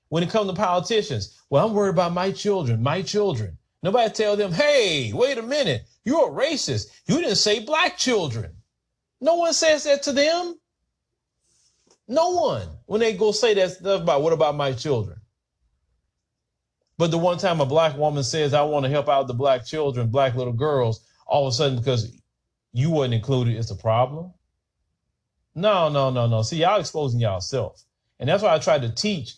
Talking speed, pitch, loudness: 190 wpm, 150 Hz, -22 LUFS